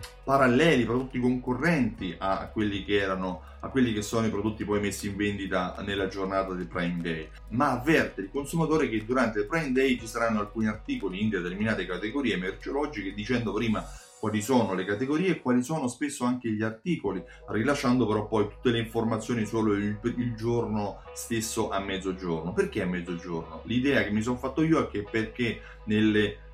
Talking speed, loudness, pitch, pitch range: 175 wpm, -28 LUFS, 110 Hz, 100-125 Hz